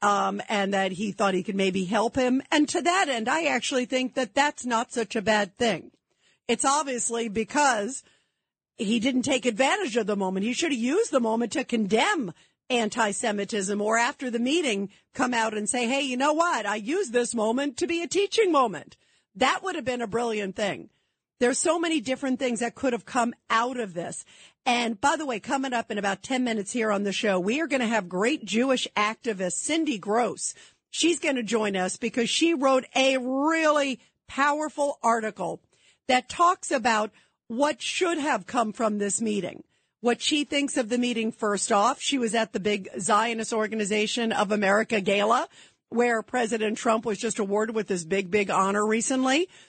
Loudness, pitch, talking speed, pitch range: -25 LUFS, 235 Hz, 195 wpm, 210-270 Hz